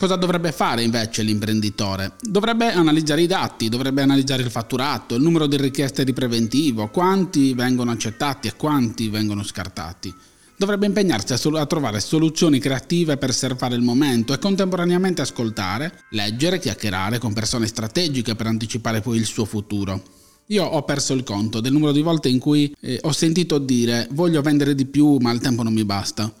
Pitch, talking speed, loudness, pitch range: 130 Hz, 175 wpm, -20 LUFS, 110-155 Hz